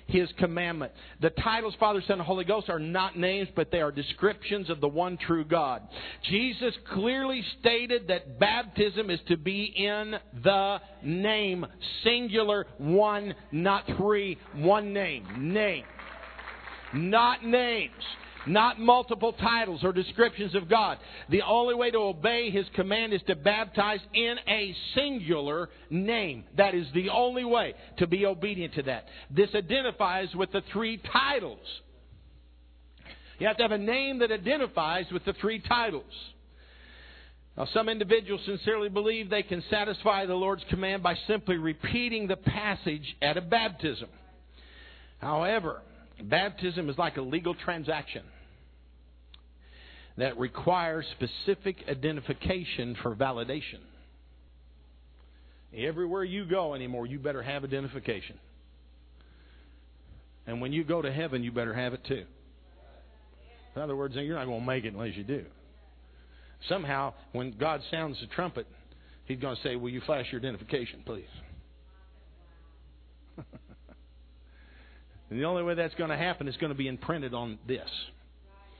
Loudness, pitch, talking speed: -29 LUFS, 165 Hz, 140 wpm